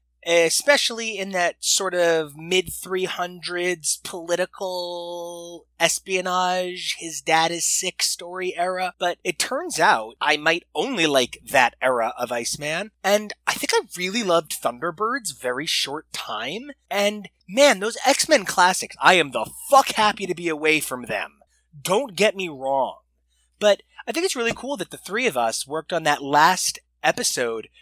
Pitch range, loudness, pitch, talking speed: 160-205 Hz, -22 LUFS, 180 Hz, 155 wpm